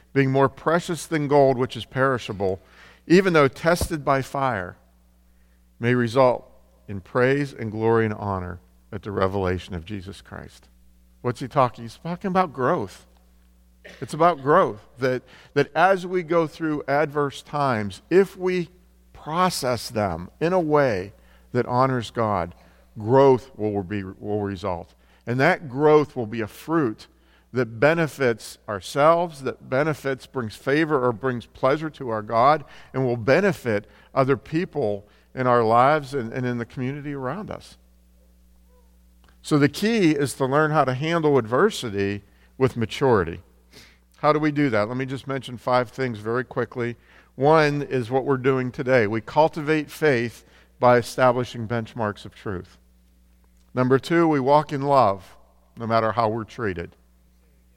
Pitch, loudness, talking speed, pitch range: 125 Hz, -23 LUFS, 150 wpm, 100-145 Hz